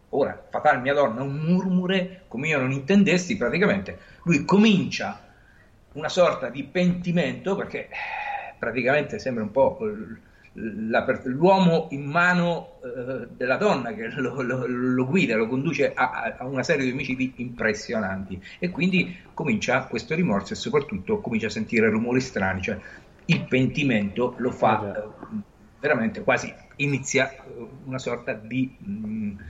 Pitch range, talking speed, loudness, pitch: 130-190 Hz, 130 wpm, -24 LUFS, 150 Hz